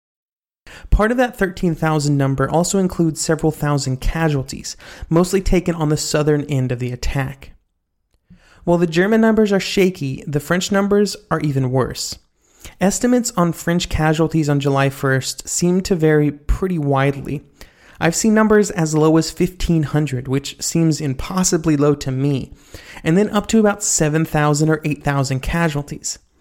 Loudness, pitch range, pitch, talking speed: -18 LUFS, 140-180 Hz, 155 Hz, 150 wpm